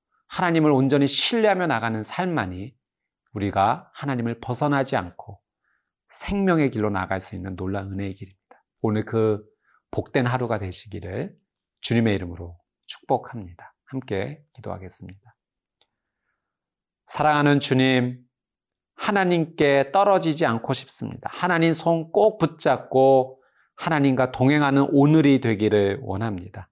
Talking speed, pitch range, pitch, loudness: 290 characters per minute, 100-150 Hz, 125 Hz, -22 LUFS